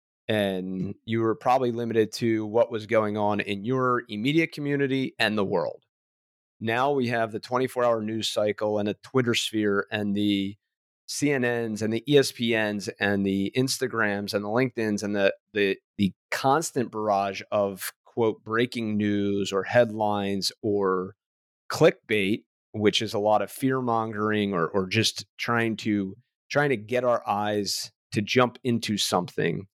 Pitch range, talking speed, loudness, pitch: 100-120 Hz, 150 wpm, -26 LUFS, 110 Hz